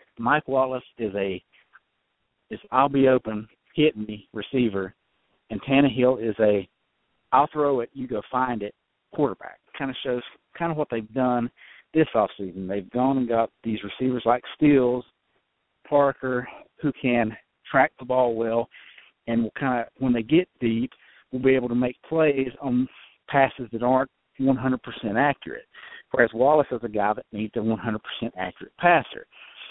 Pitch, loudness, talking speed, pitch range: 125 Hz, -24 LUFS, 170 wpm, 115-135 Hz